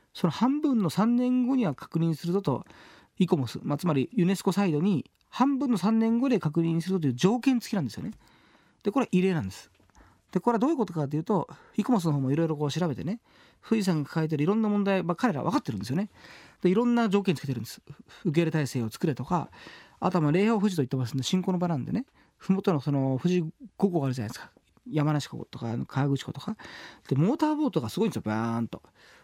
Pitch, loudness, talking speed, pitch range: 180 Hz, -27 LUFS, 455 characters per minute, 145-215 Hz